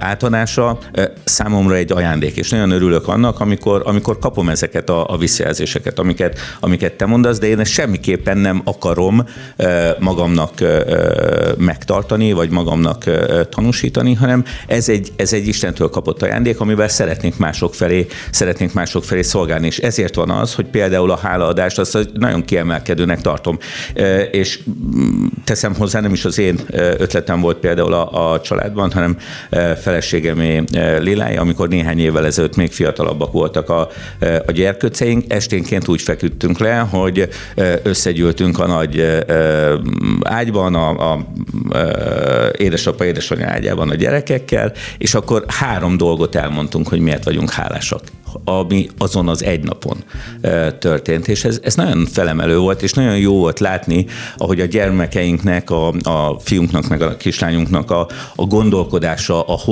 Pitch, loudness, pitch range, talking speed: 95 Hz, -15 LUFS, 85-105 Hz, 145 wpm